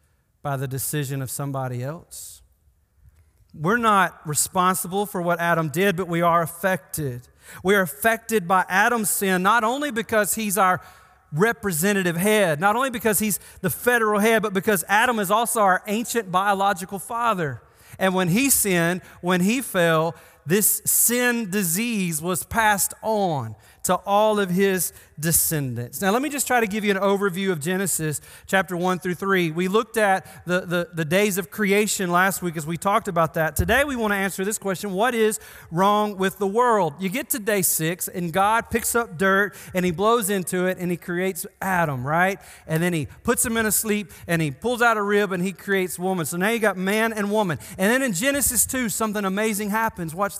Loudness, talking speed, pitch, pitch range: -22 LUFS, 195 wpm, 195 Hz, 170-215 Hz